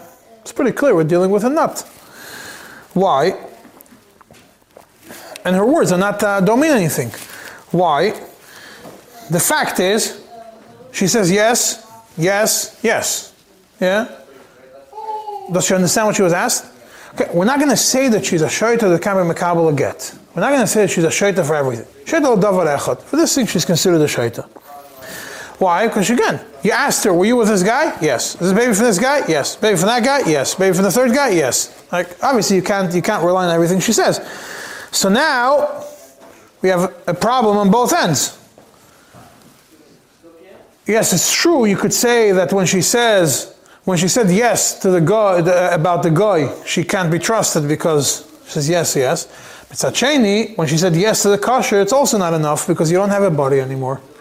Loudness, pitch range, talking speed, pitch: -15 LUFS, 175-230 Hz, 190 wpm, 200 Hz